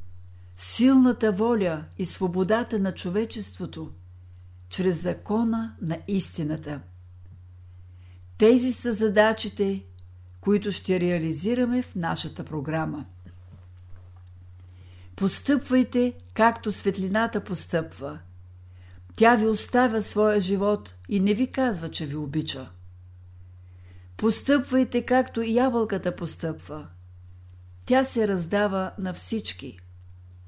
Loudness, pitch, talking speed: -25 LUFS, 175 Hz, 90 wpm